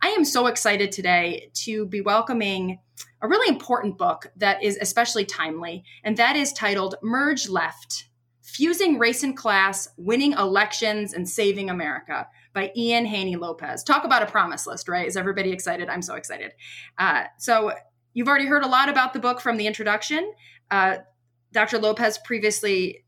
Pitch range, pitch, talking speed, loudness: 185-240 Hz, 210 Hz, 165 wpm, -23 LUFS